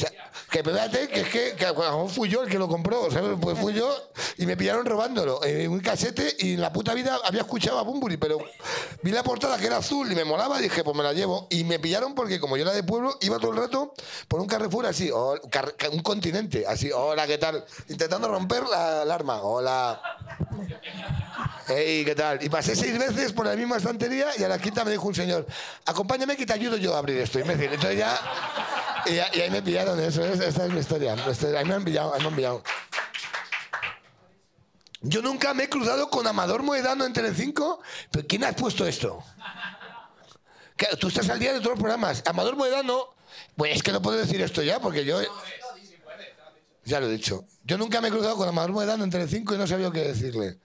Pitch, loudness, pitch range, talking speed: 195 Hz, -26 LUFS, 160-240 Hz, 225 wpm